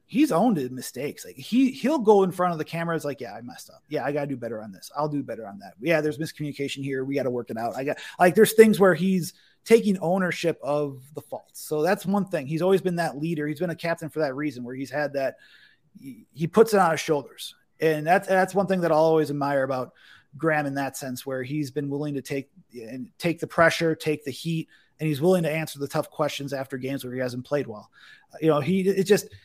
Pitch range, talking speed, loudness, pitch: 140-180 Hz, 255 wpm, -25 LUFS, 155 Hz